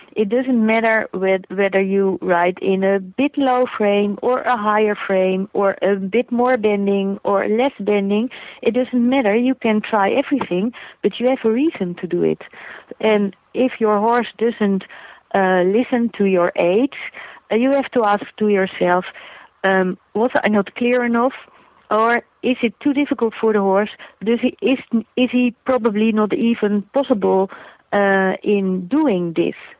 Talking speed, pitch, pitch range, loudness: 165 wpm, 215 Hz, 195-245 Hz, -18 LUFS